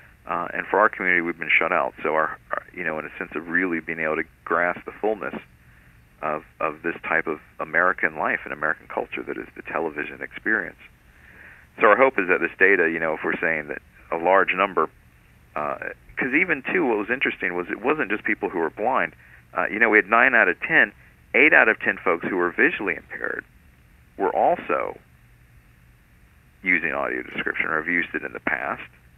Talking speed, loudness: 210 wpm, -22 LUFS